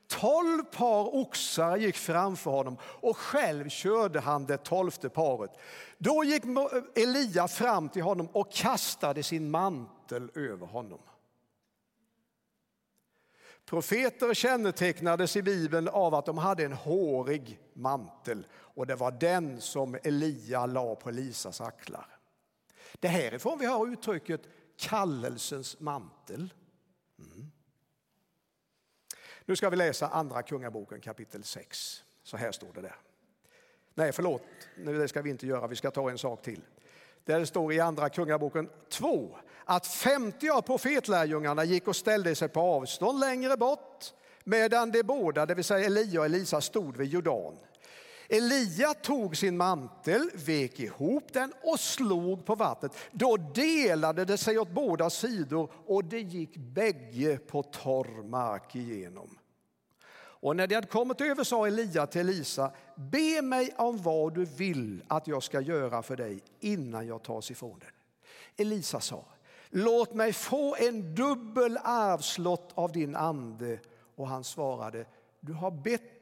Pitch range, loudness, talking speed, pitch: 145-225 Hz, -31 LUFS, 145 wpm, 175 Hz